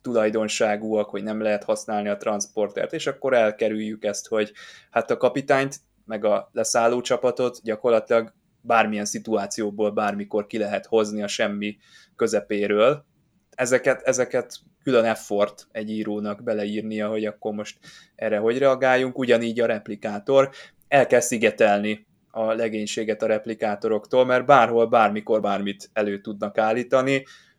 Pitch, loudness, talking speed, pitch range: 110 Hz, -23 LUFS, 130 wpm, 105-120 Hz